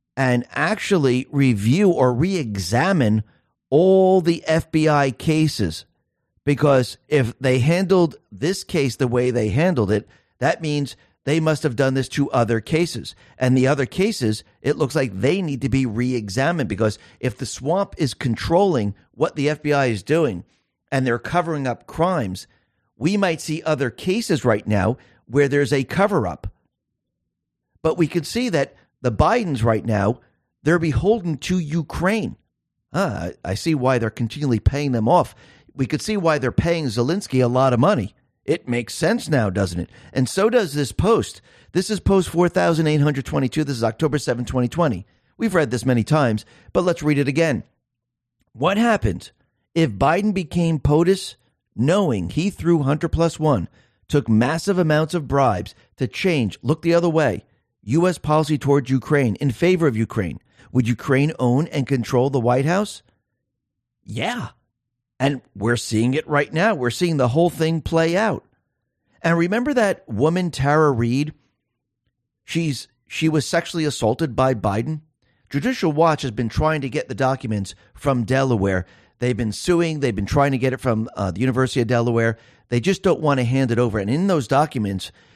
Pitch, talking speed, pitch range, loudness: 135 Hz, 170 wpm, 120-160 Hz, -20 LUFS